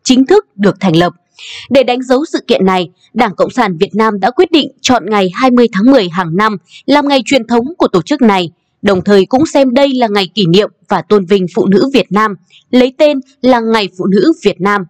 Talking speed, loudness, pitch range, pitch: 235 wpm, -11 LUFS, 190-260 Hz, 215 Hz